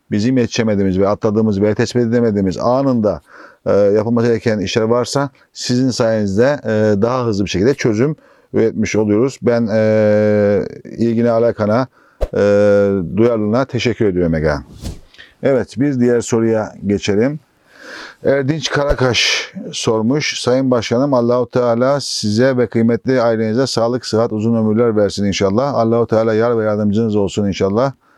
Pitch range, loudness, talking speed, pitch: 105-120 Hz, -15 LUFS, 125 wpm, 115 Hz